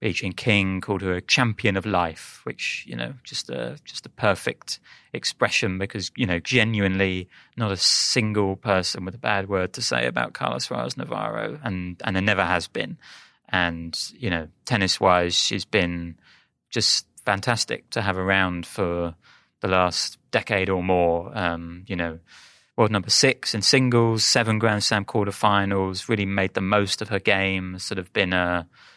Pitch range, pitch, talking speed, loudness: 90-105 Hz, 95 Hz, 170 wpm, -23 LUFS